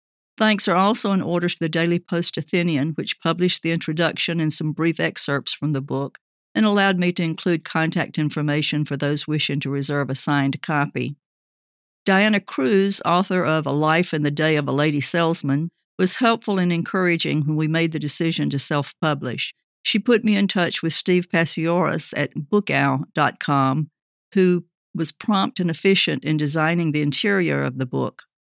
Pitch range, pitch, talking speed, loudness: 150-180 Hz, 165 Hz, 170 wpm, -21 LUFS